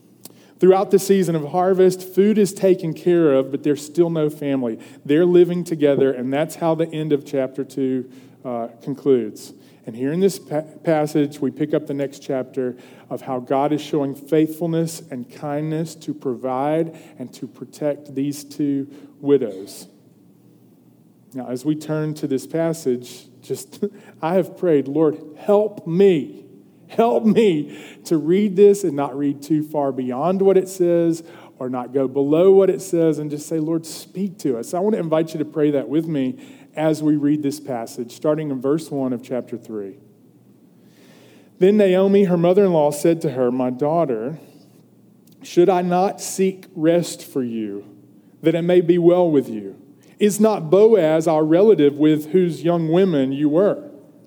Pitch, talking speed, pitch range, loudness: 155 Hz, 170 wpm, 140-175 Hz, -19 LUFS